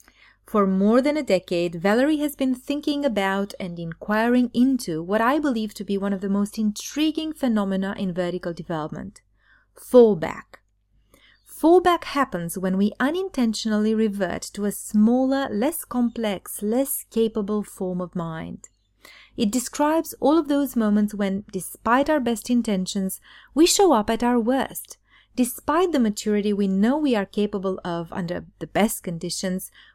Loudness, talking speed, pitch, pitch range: -23 LUFS, 150 wpm, 215 Hz, 195-260 Hz